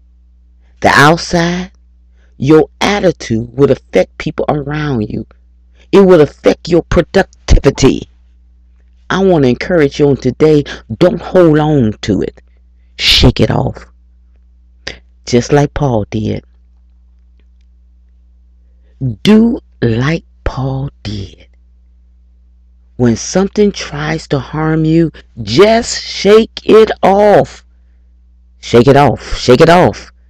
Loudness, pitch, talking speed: -11 LUFS, 110 Hz, 105 wpm